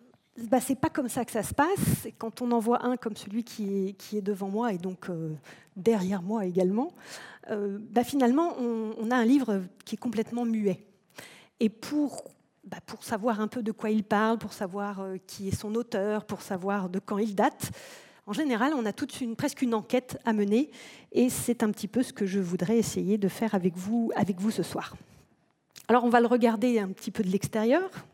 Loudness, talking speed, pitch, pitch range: -29 LUFS, 220 wpm, 220 Hz, 200-245 Hz